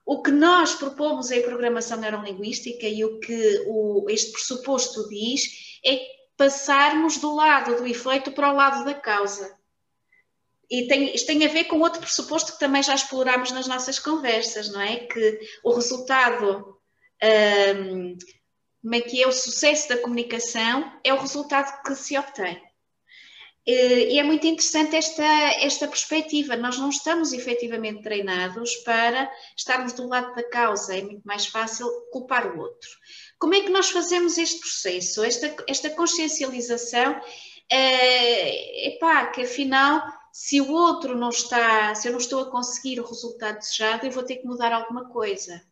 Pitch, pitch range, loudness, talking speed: 255 Hz, 230-290 Hz, -22 LUFS, 160 wpm